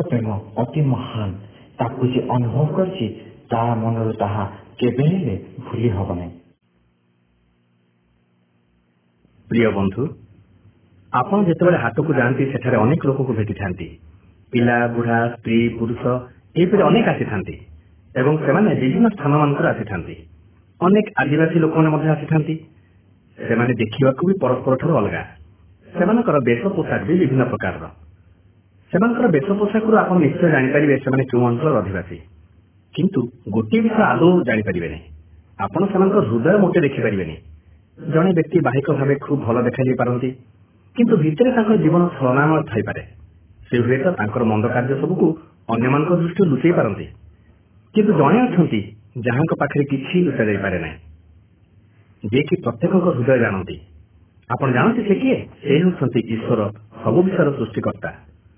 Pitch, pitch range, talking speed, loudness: 120 Hz, 100-155 Hz, 110 wpm, -19 LUFS